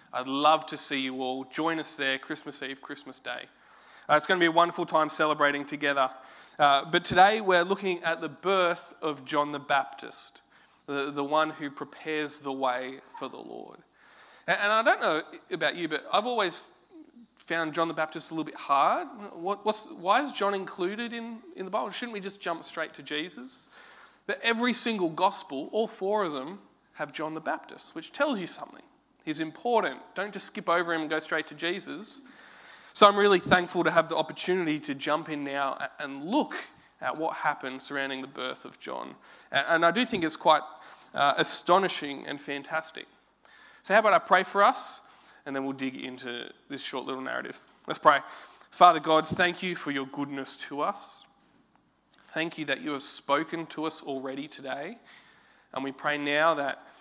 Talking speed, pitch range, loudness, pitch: 190 wpm, 145-195 Hz, -28 LUFS, 160 Hz